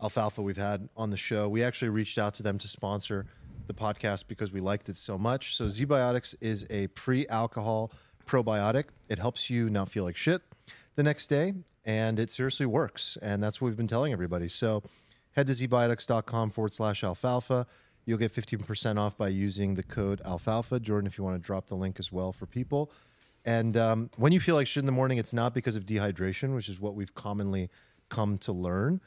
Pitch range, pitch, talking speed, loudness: 100-125 Hz, 110 Hz, 210 wpm, -31 LUFS